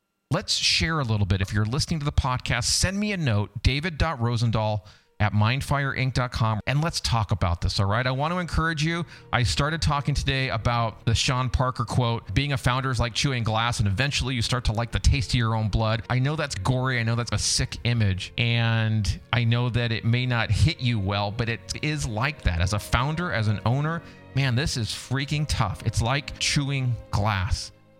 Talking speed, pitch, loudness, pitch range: 210 wpm, 120 Hz, -25 LUFS, 105-135 Hz